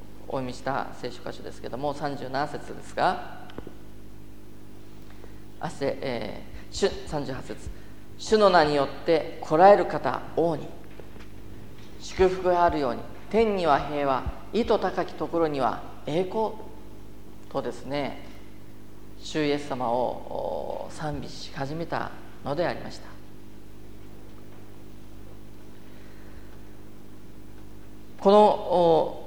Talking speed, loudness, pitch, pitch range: 180 characters per minute, -26 LUFS, 110 Hz, 100-155 Hz